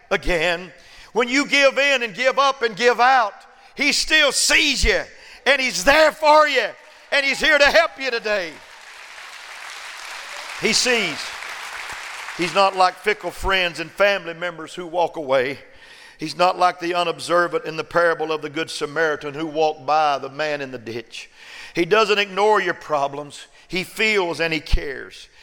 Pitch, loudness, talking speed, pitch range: 180 Hz, -19 LUFS, 165 wpm, 160-245 Hz